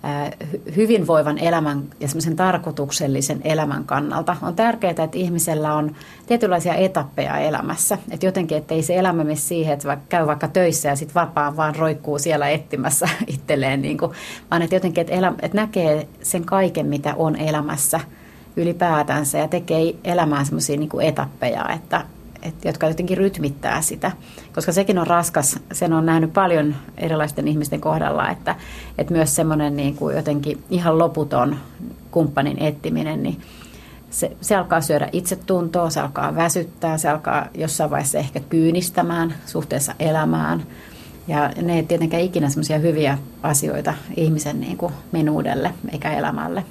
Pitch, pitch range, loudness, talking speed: 160 Hz, 150-175 Hz, -20 LUFS, 145 wpm